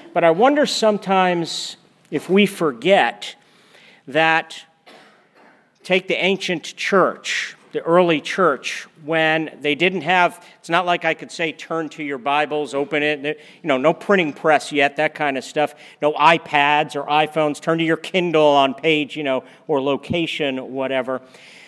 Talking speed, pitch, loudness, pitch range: 155 wpm, 160 Hz, -19 LUFS, 150-175 Hz